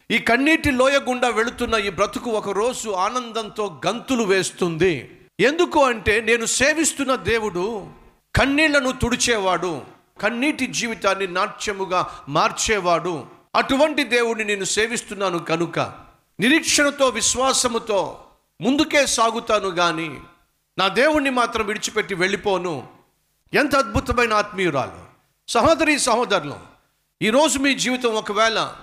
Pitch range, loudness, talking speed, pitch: 195-260 Hz, -20 LUFS, 95 wpm, 225 Hz